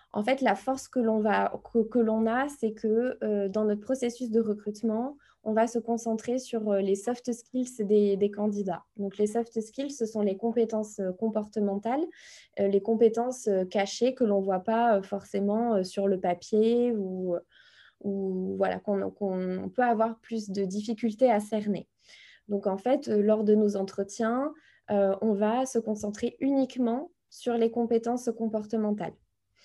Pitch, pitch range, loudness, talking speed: 220 Hz, 200-235 Hz, -28 LUFS, 165 wpm